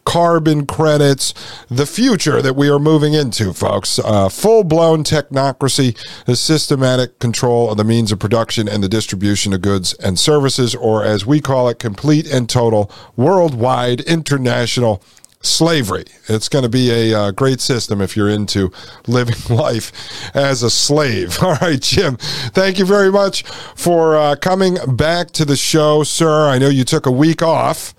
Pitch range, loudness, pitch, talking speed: 115-155 Hz, -14 LUFS, 130 Hz, 165 wpm